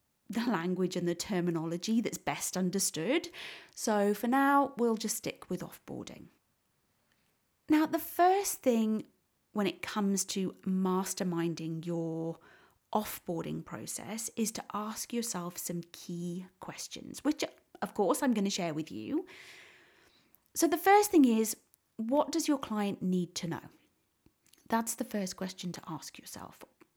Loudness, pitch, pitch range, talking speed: -32 LUFS, 205 Hz, 175-260 Hz, 140 wpm